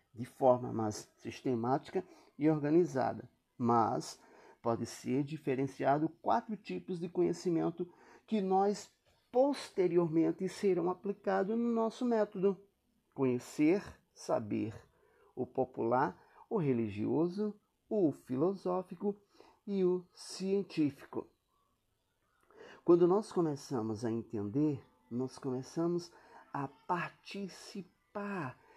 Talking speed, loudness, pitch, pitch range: 90 wpm, -35 LUFS, 175 Hz, 135-200 Hz